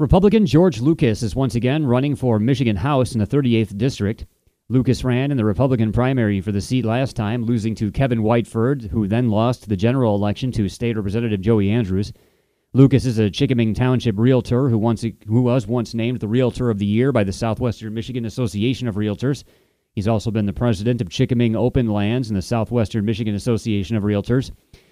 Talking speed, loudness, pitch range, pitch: 195 wpm, -19 LUFS, 110-125 Hz, 115 Hz